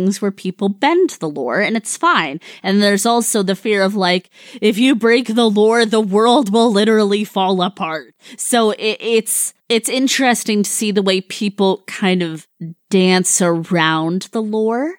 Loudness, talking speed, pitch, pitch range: -15 LUFS, 170 wpm, 210 Hz, 190-230 Hz